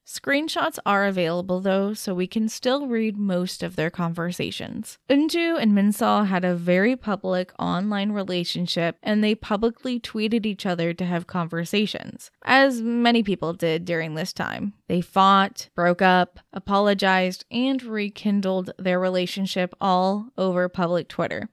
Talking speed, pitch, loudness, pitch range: 140 wpm, 195 Hz, -23 LUFS, 180-220 Hz